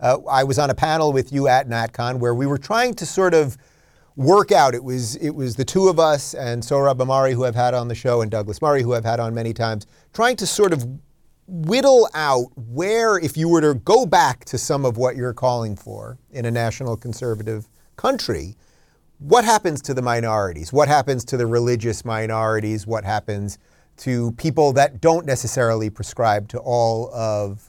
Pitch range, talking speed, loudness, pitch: 115-150 Hz, 200 wpm, -19 LUFS, 125 Hz